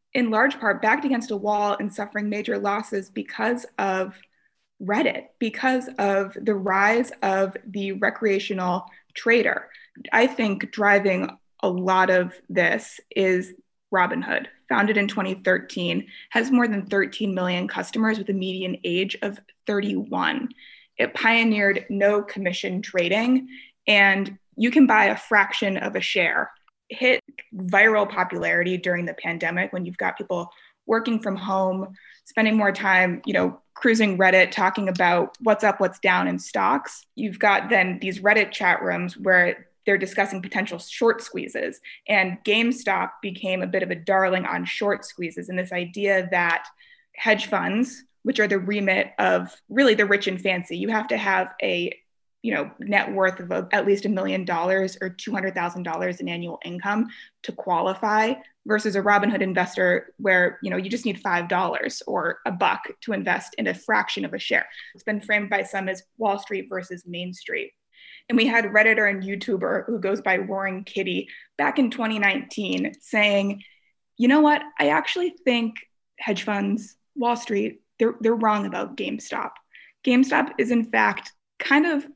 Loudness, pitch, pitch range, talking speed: -23 LUFS, 200 Hz, 190-225 Hz, 160 wpm